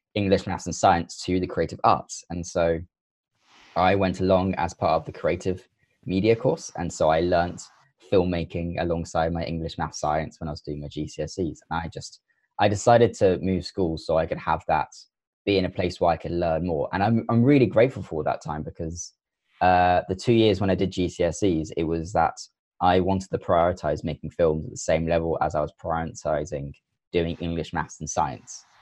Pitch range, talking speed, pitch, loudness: 80-95 Hz, 200 wpm, 85 Hz, -25 LUFS